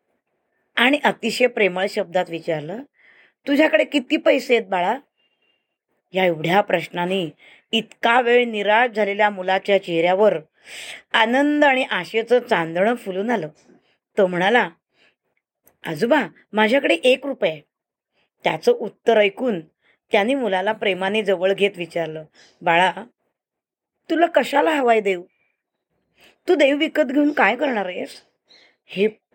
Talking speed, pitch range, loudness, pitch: 110 wpm, 190-265 Hz, -19 LUFS, 215 Hz